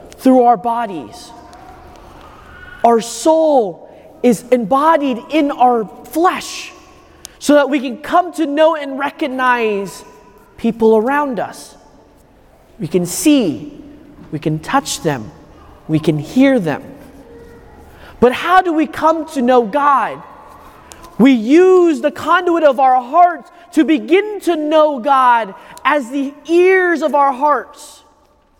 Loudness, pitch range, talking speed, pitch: -14 LUFS, 245-315 Hz, 125 wpm, 285 Hz